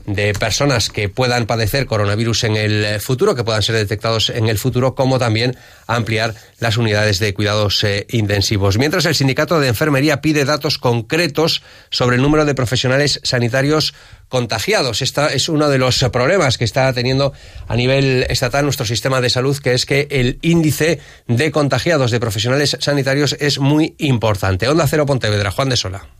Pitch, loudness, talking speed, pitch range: 125 Hz, -16 LUFS, 170 wpm, 115-140 Hz